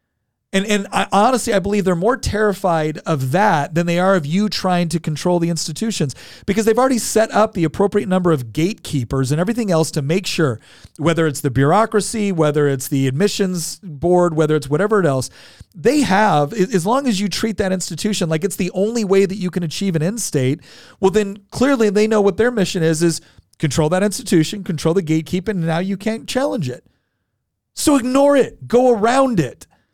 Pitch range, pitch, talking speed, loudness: 160-210 Hz, 185 Hz, 200 wpm, -17 LUFS